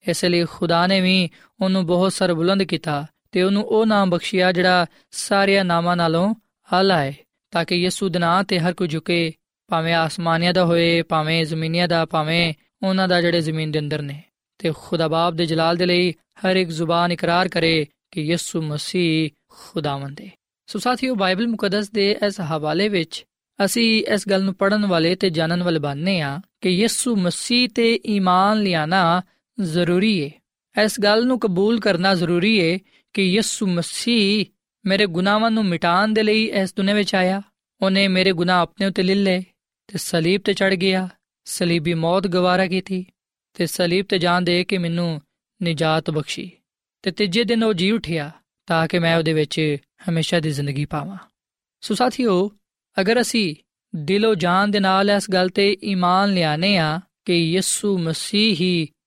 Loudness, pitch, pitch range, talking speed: -20 LUFS, 185 Hz, 170-200 Hz, 165 wpm